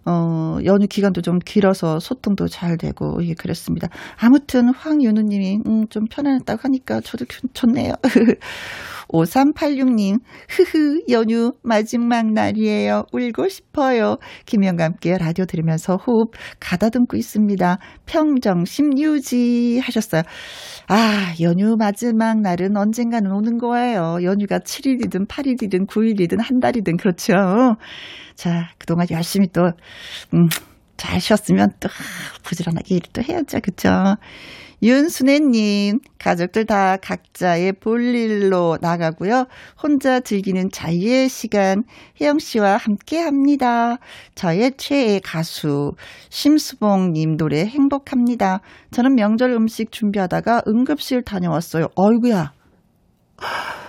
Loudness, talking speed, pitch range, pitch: -18 LUFS, 265 characters per minute, 180-250 Hz, 215 Hz